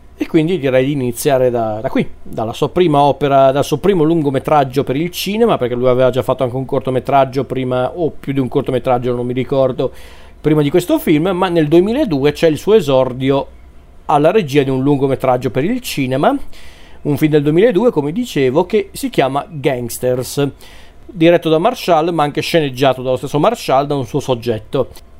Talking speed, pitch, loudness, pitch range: 185 wpm, 140 Hz, -15 LUFS, 130-160 Hz